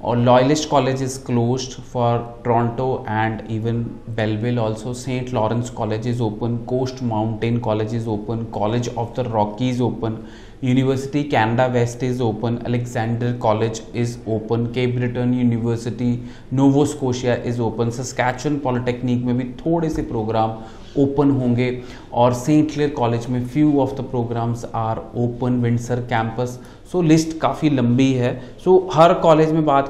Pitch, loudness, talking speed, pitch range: 120 Hz, -20 LUFS, 155 wpm, 115-130 Hz